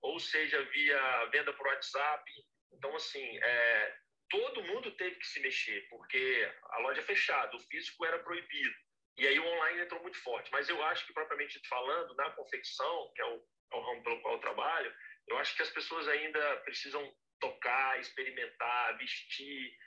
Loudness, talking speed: -35 LUFS, 180 wpm